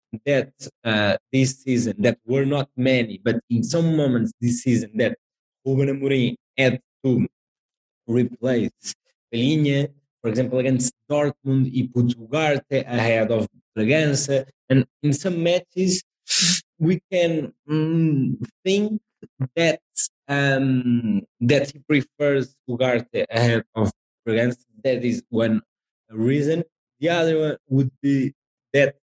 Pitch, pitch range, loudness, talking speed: 135 Hz, 120-145 Hz, -22 LUFS, 120 wpm